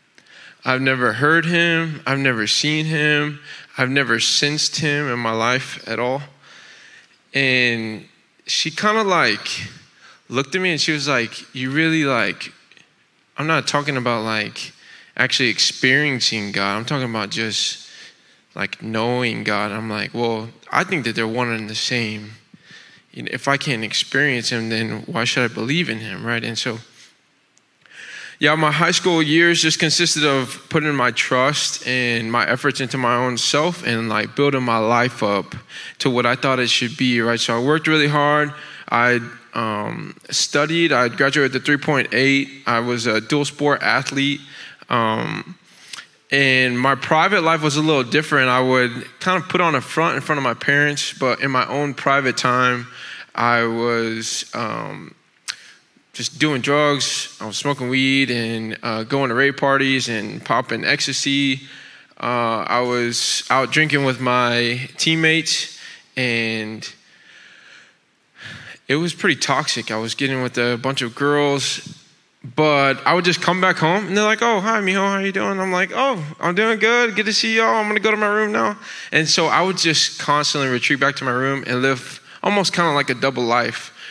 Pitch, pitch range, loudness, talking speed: 135 Hz, 120-150 Hz, -18 LUFS, 175 wpm